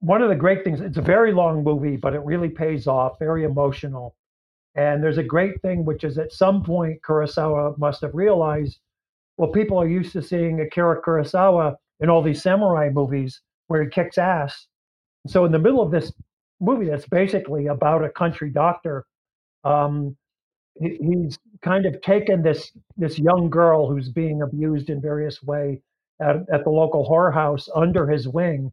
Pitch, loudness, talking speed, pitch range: 160 Hz, -21 LUFS, 180 wpm, 145-175 Hz